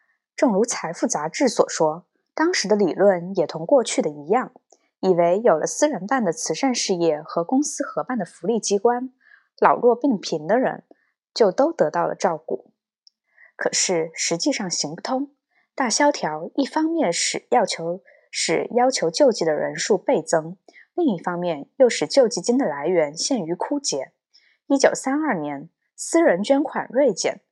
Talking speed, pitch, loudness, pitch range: 240 characters per minute, 240 Hz, -21 LUFS, 175-275 Hz